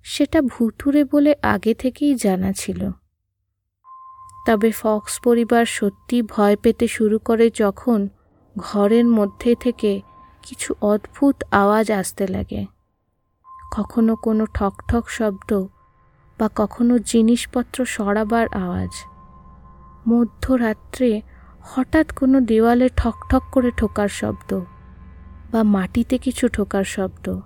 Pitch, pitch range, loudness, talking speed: 220 Hz, 195-245 Hz, -20 LUFS, 100 wpm